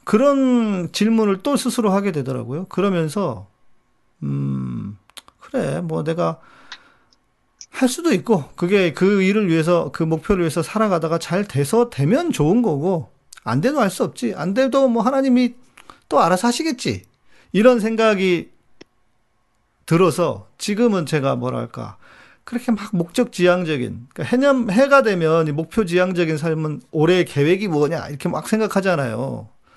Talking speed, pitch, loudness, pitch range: 290 characters per minute, 180 Hz, -19 LUFS, 155-225 Hz